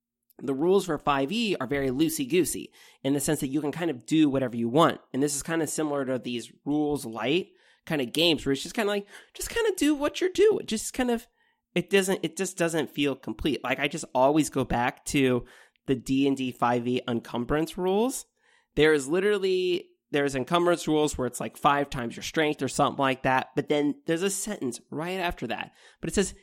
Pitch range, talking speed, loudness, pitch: 135-195 Hz, 225 wpm, -27 LUFS, 150 Hz